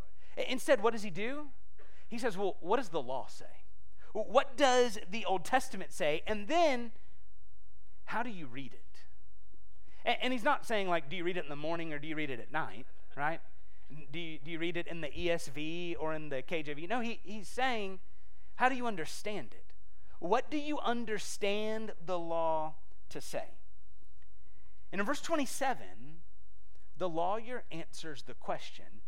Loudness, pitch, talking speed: -36 LUFS, 170 Hz, 175 wpm